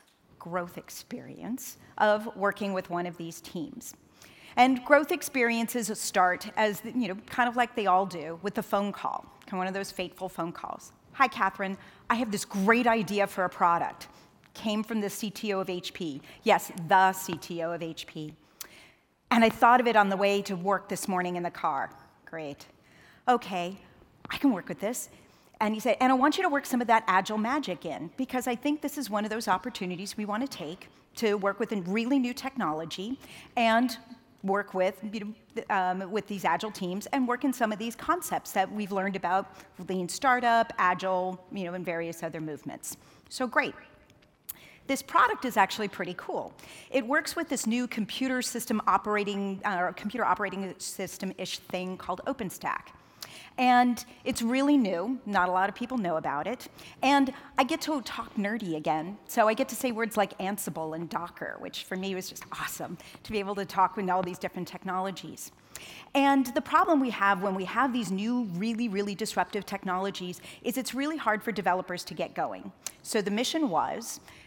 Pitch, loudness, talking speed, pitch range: 205 Hz, -29 LUFS, 190 wpm, 185-245 Hz